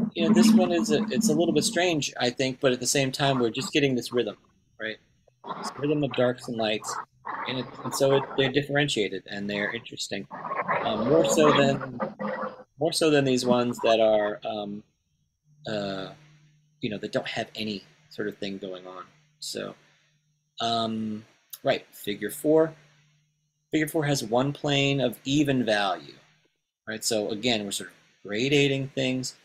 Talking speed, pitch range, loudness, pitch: 170 wpm, 110-150 Hz, -26 LUFS, 135 Hz